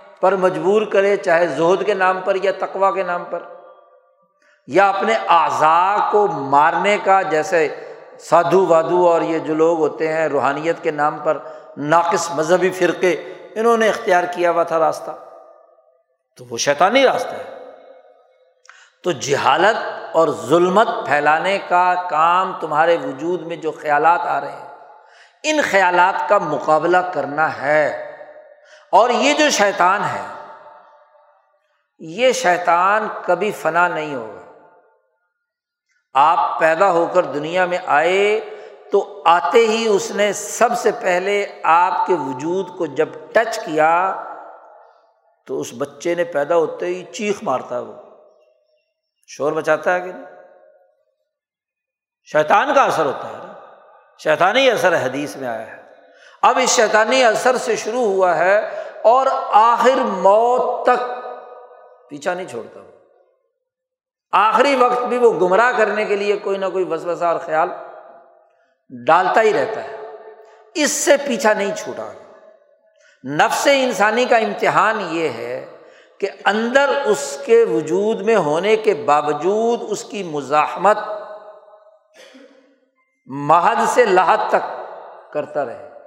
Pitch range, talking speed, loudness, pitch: 170-260 Hz, 135 wpm, -17 LUFS, 205 Hz